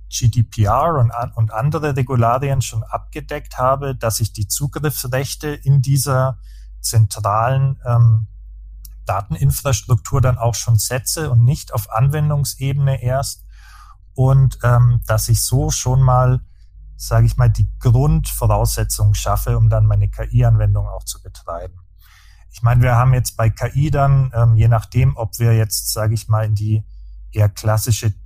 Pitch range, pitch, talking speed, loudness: 105-130 Hz, 115 Hz, 140 wpm, -17 LUFS